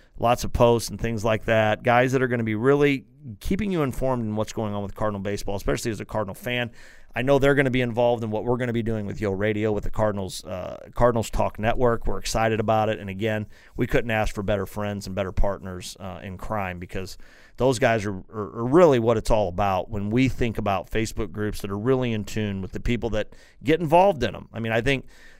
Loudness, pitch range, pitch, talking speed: -24 LUFS, 105-120 Hz, 110 Hz, 265 wpm